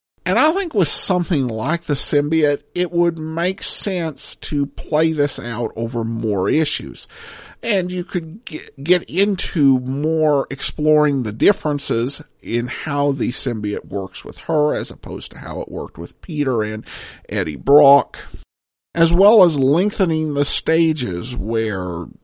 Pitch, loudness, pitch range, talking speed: 145 Hz, -19 LUFS, 125-170 Hz, 145 wpm